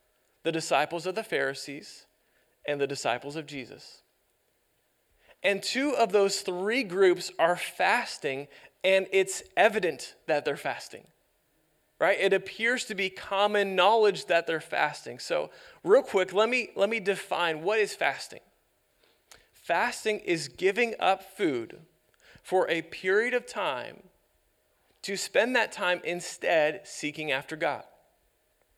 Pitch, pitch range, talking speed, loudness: 190 Hz, 170-210 Hz, 130 wpm, -28 LUFS